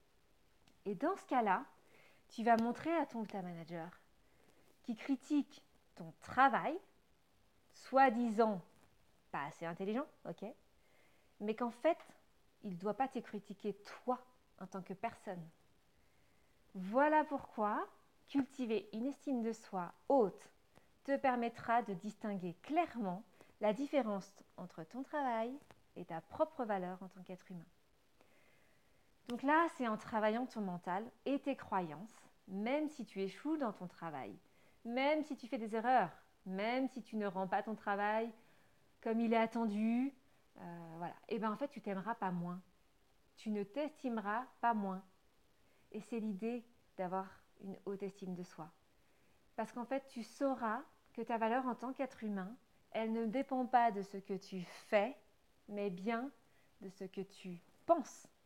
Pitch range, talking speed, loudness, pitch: 195-255 Hz, 155 wpm, -39 LUFS, 225 Hz